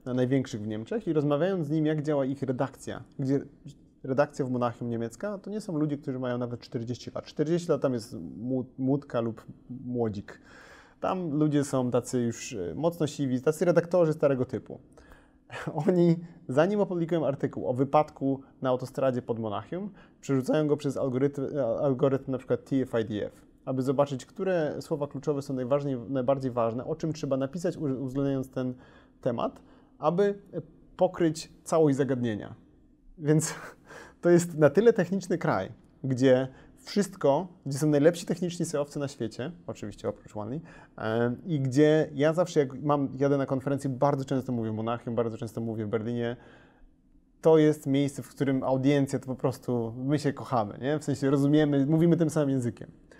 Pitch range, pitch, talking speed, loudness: 125-155 Hz, 140 Hz, 155 wpm, -28 LUFS